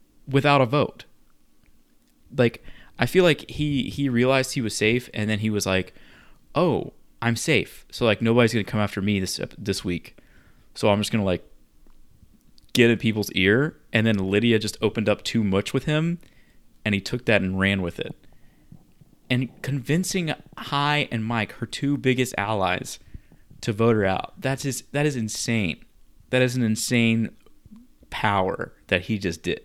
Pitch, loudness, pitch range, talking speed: 115 Hz, -23 LUFS, 100-135 Hz, 175 wpm